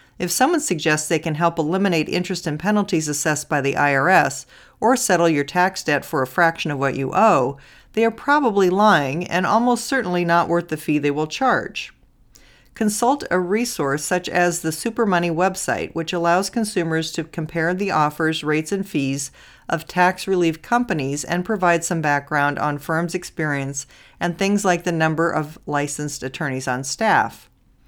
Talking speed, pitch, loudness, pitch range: 170 wpm, 170 Hz, -20 LUFS, 150-185 Hz